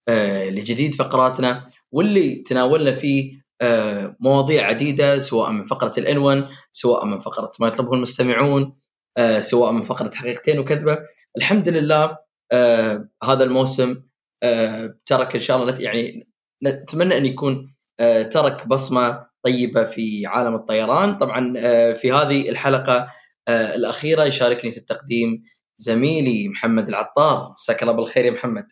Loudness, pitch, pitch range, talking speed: -19 LUFS, 130 Hz, 115-140 Hz, 135 wpm